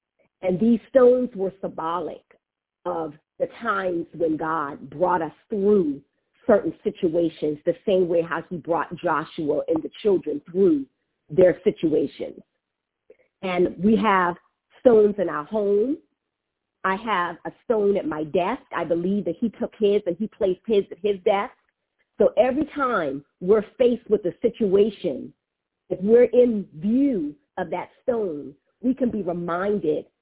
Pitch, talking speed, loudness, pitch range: 195 Hz, 145 wpm, -23 LUFS, 170-230 Hz